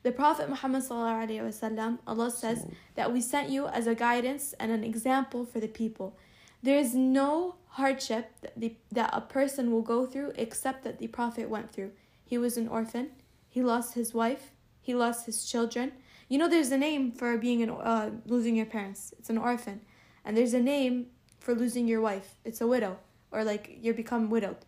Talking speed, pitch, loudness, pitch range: 190 wpm, 235 Hz, -31 LUFS, 225-255 Hz